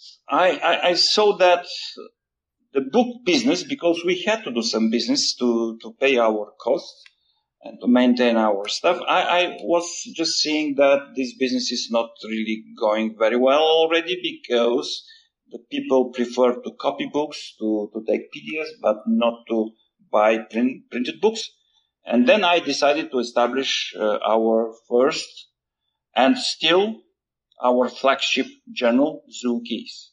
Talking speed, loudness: 145 wpm, -21 LUFS